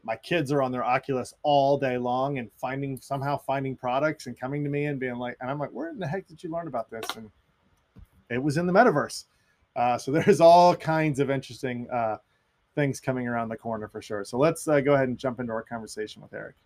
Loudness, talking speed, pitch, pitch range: -26 LUFS, 240 wpm, 130 Hz, 115-145 Hz